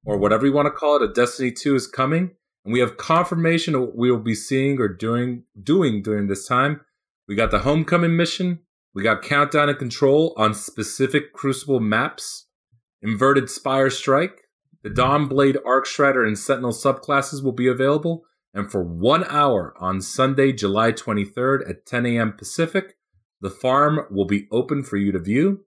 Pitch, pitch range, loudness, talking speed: 130 Hz, 110-145 Hz, -20 LUFS, 180 wpm